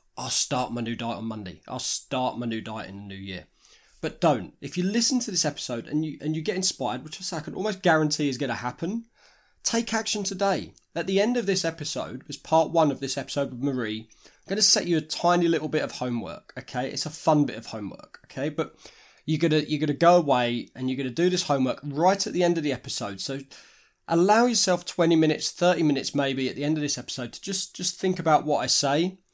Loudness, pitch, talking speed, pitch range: -25 LUFS, 155 Hz, 235 wpm, 130-180 Hz